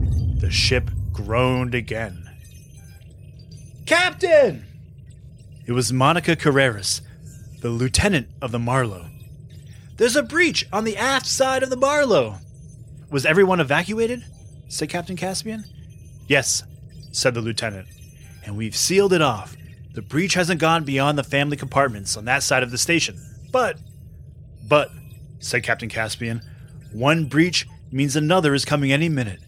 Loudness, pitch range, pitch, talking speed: -20 LUFS, 115-165 Hz, 135 Hz, 135 wpm